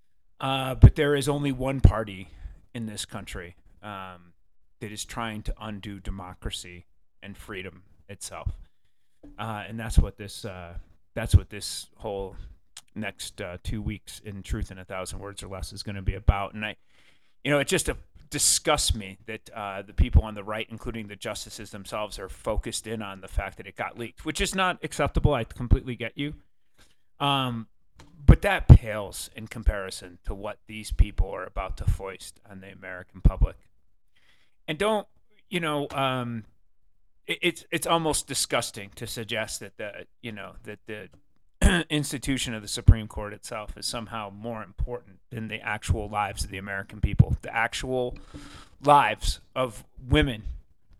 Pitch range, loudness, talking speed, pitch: 95-115 Hz, -27 LUFS, 170 wpm, 105 Hz